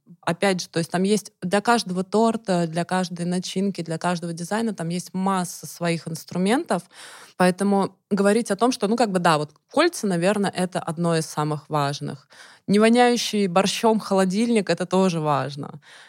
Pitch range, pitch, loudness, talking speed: 170-205 Hz, 185 Hz, -22 LUFS, 165 wpm